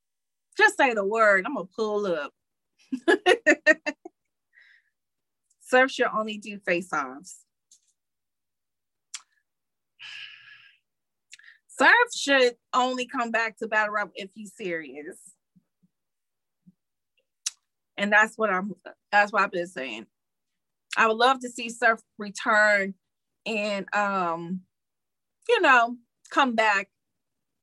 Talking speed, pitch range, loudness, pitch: 100 wpm, 200-260 Hz, -24 LUFS, 220 Hz